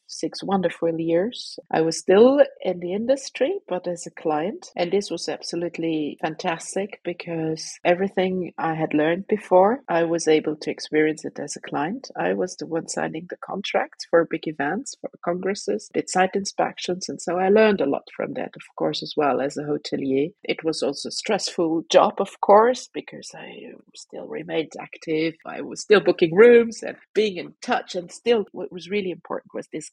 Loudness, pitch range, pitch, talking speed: -23 LUFS, 165-205 Hz, 180 Hz, 185 wpm